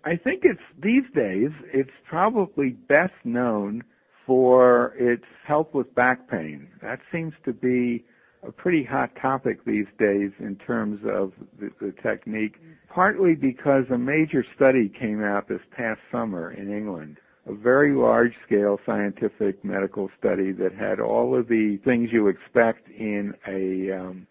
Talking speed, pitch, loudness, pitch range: 150 wpm, 120 Hz, -23 LUFS, 100-135 Hz